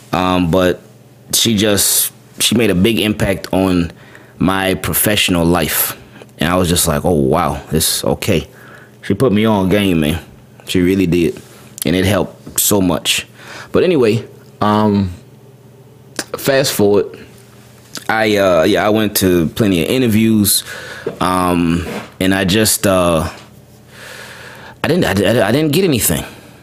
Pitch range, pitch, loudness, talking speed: 90-110 Hz, 100 Hz, -14 LUFS, 140 wpm